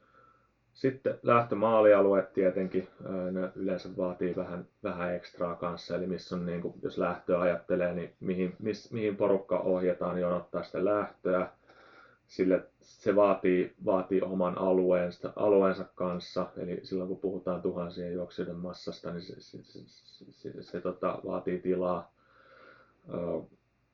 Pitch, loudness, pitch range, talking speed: 90 Hz, -31 LUFS, 90-95 Hz, 135 wpm